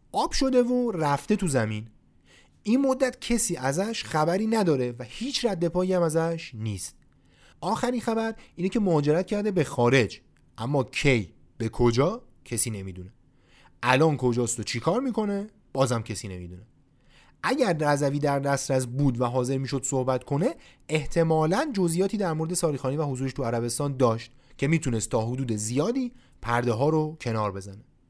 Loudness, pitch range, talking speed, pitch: -26 LUFS, 120-180 Hz, 150 wpm, 140 Hz